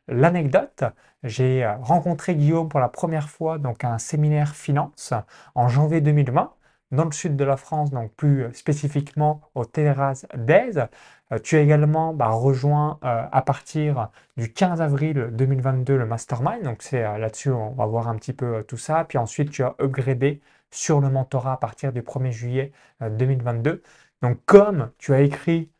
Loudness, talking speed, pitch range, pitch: -22 LUFS, 175 wpm, 125-150 Hz, 140 Hz